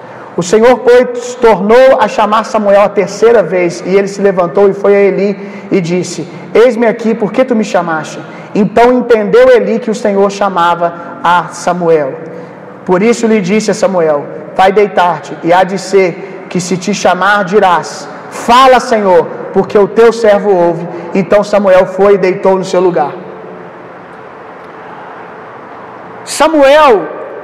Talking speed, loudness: 155 wpm, -9 LUFS